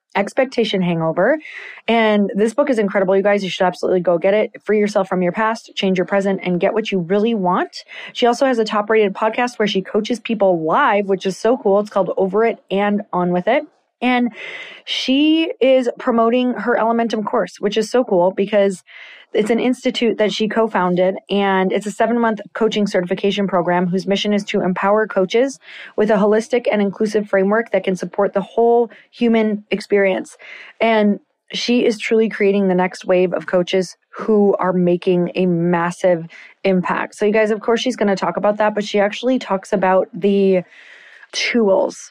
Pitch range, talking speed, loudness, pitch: 190-230 Hz, 190 wpm, -17 LUFS, 205 Hz